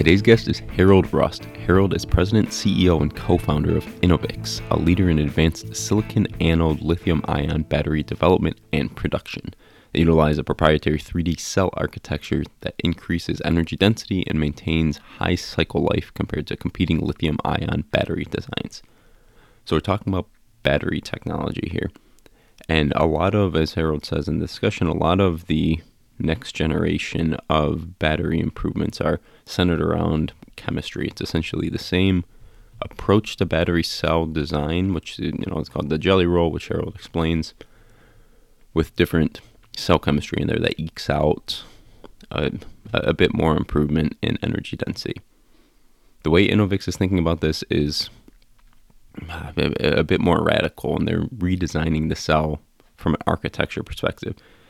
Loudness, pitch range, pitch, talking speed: -22 LUFS, 80-95 Hz, 85 Hz, 150 wpm